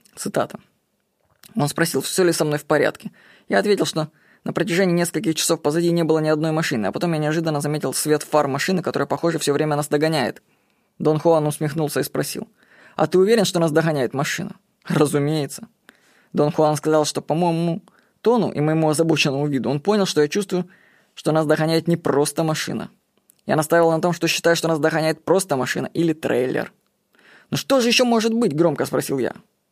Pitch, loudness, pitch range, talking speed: 160 Hz, -20 LUFS, 150-180 Hz, 190 wpm